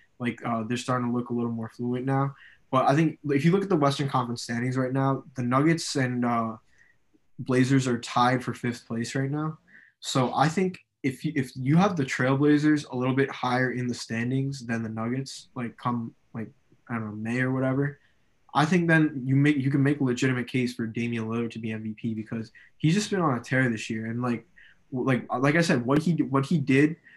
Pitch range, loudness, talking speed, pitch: 120-140 Hz, -26 LUFS, 225 wpm, 130 Hz